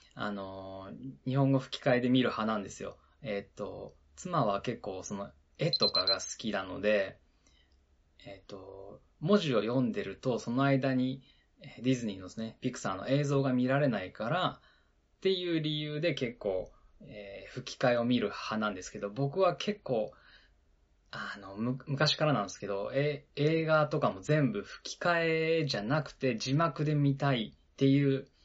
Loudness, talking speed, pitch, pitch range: -32 LUFS, 300 characters per minute, 130 Hz, 100-145 Hz